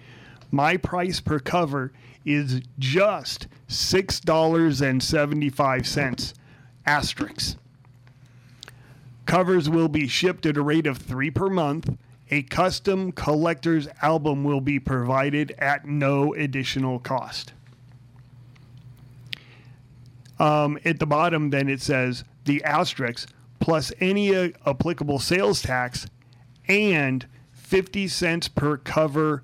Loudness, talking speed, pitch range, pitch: -23 LUFS, 100 wpm, 130-160 Hz, 140 Hz